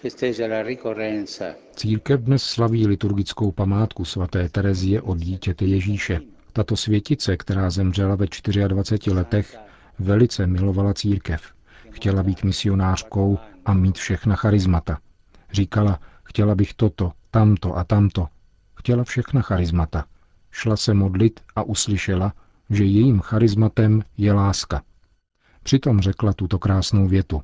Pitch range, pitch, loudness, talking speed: 95-110 Hz, 100 Hz, -21 LUFS, 115 wpm